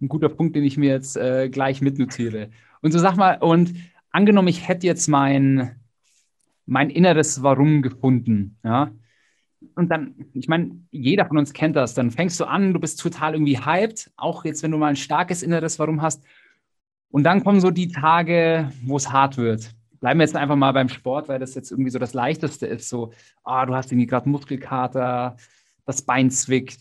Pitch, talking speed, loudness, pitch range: 140 Hz, 195 wpm, -20 LUFS, 130-165 Hz